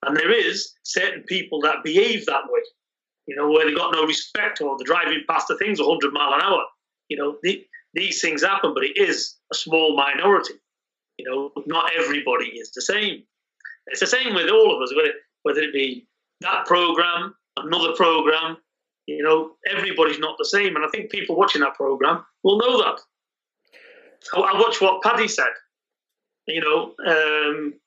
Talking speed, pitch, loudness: 180 wpm, 195 Hz, -20 LUFS